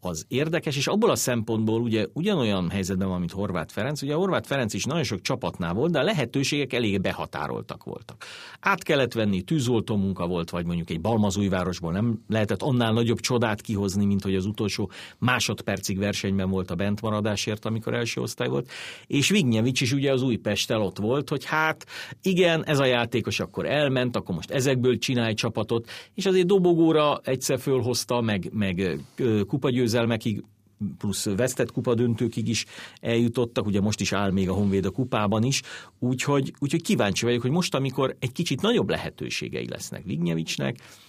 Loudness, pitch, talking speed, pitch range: -25 LUFS, 115 Hz, 170 wpm, 100-130 Hz